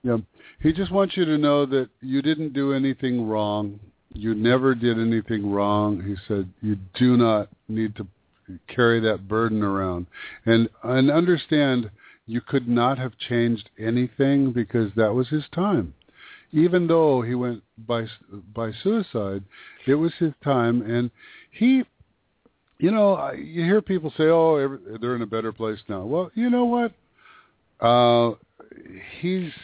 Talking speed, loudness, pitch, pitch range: 155 wpm, -23 LUFS, 120 Hz, 110-150 Hz